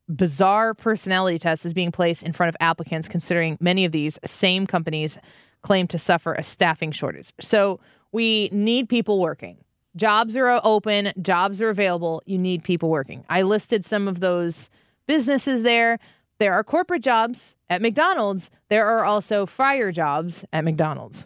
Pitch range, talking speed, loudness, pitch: 165-220 Hz, 160 wpm, -21 LUFS, 185 Hz